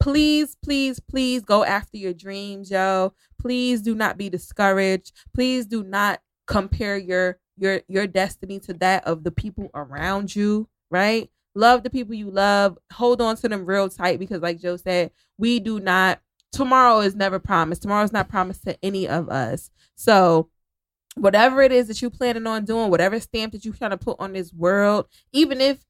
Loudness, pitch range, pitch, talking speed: -21 LUFS, 185-225 Hz, 200 Hz, 190 wpm